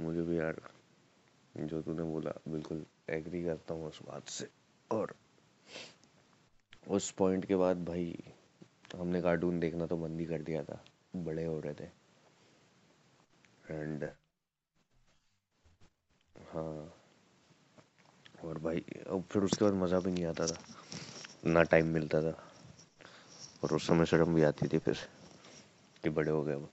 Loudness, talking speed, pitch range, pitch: -35 LUFS, 140 wpm, 80-85 Hz, 80 Hz